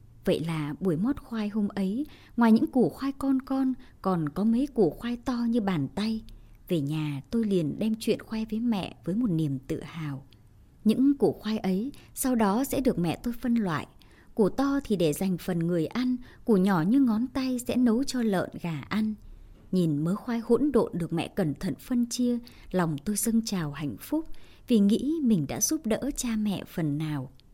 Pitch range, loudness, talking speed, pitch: 170-240 Hz, -28 LUFS, 205 wpm, 215 Hz